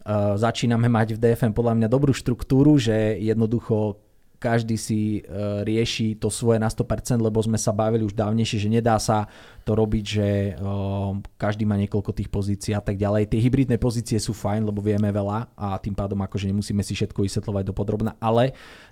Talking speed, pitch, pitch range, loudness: 180 wpm, 110 Hz, 105-115 Hz, -23 LUFS